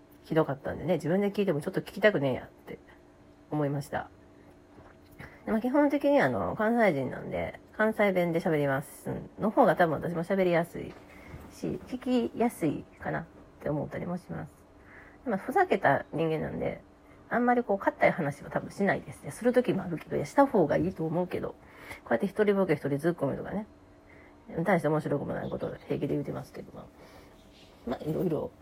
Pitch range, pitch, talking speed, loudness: 145-215 Hz, 175 Hz, 390 characters per minute, -29 LUFS